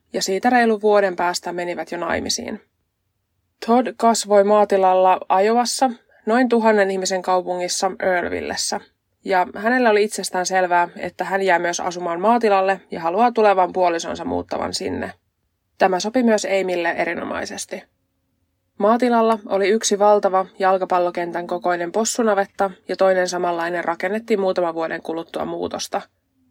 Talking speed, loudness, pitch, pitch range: 120 wpm, -19 LUFS, 185 Hz, 175-210 Hz